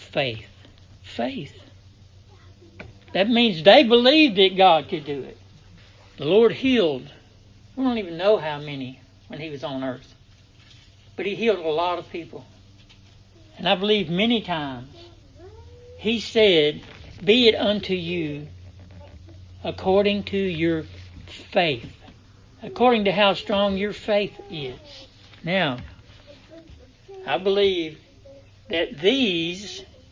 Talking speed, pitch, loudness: 120 wpm, 130 Hz, -21 LUFS